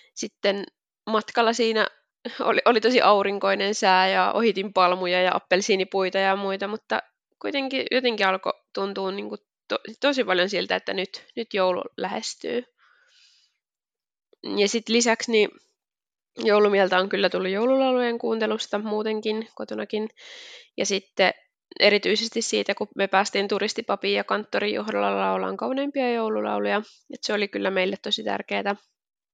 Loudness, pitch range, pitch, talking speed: -24 LUFS, 190-230 Hz, 205 Hz, 130 wpm